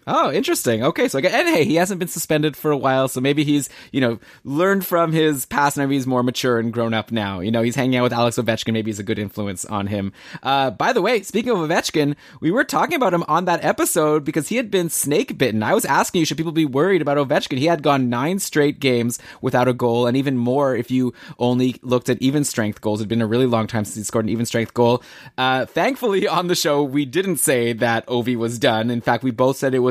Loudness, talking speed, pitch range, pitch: -19 LUFS, 265 wpm, 120-155 Hz, 130 Hz